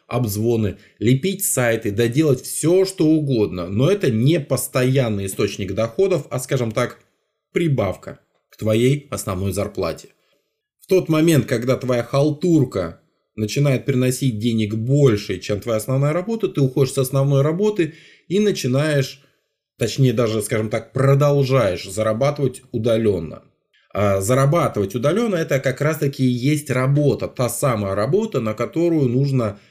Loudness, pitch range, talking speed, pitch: -19 LUFS, 115-145 Hz, 130 wpm, 130 Hz